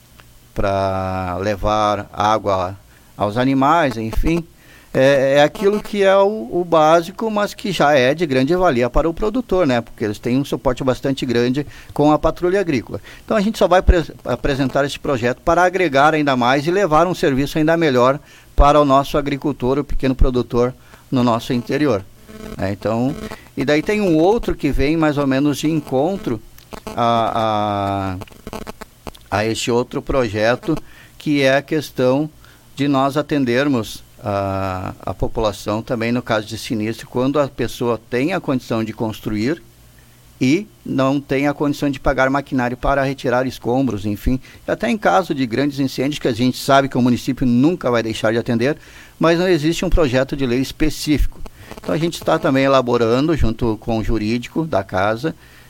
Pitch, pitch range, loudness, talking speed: 135 Hz, 115-150 Hz, -18 LUFS, 170 wpm